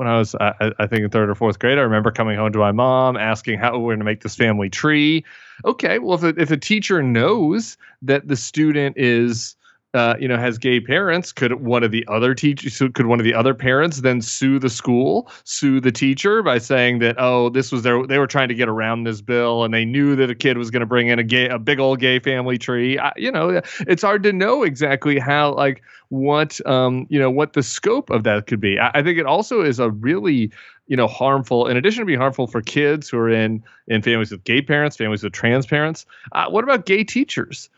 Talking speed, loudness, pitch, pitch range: 245 wpm, -18 LUFS, 125 Hz, 115-145 Hz